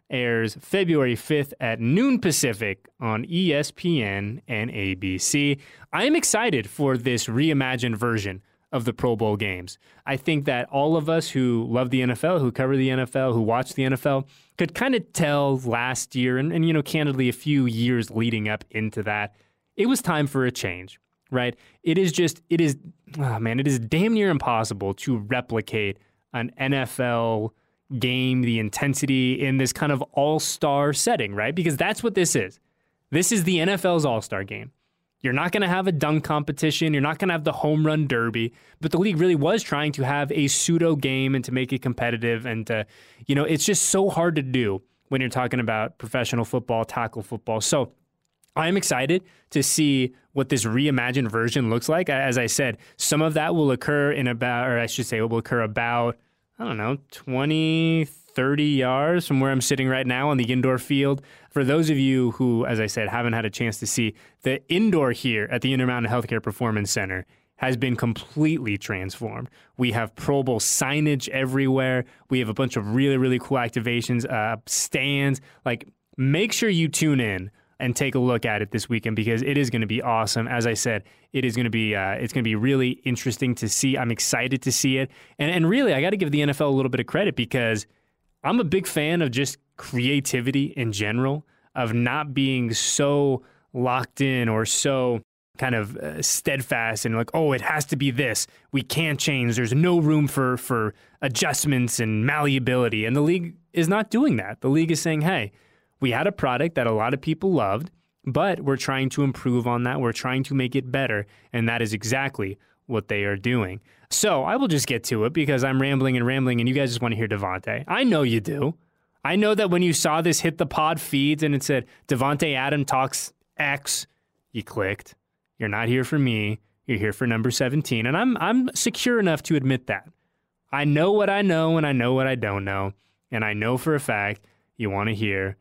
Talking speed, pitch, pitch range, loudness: 205 wpm, 130 Hz, 115-150 Hz, -23 LUFS